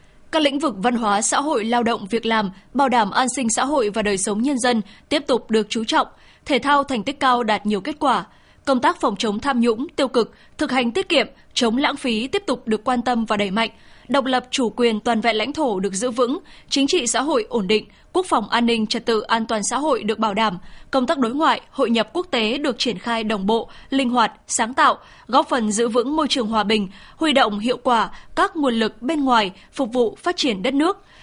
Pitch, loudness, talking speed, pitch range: 245 Hz, -20 LUFS, 250 wpm, 225-275 Hz